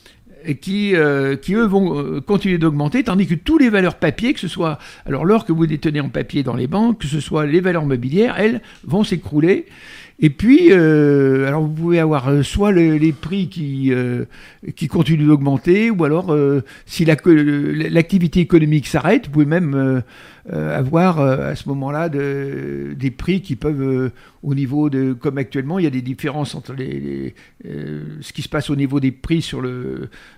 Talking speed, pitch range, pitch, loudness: 190 wpm, 135-175 Hz, 150 Hz, -17 LUFS